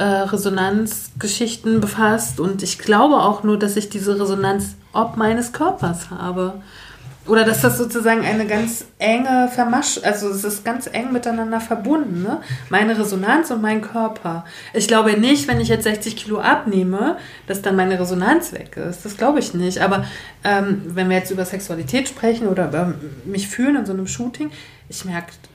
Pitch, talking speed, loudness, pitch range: 210 Hz, 170 wpm, -19 LUFS, 185-225 Hz